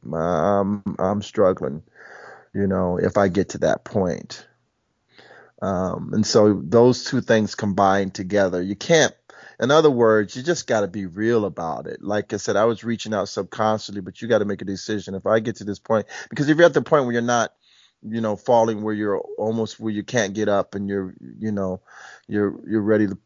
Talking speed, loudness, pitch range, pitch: 210 wpm, -21 LUFS, 100-115 Hz, 105 Hz